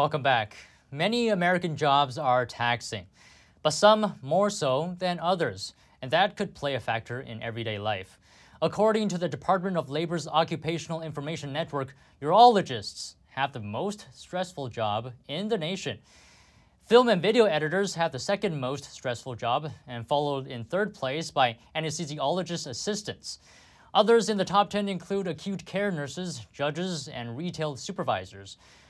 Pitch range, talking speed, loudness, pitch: 120-185 Hz, 145 wpm, -27 LUFS, 155 Hz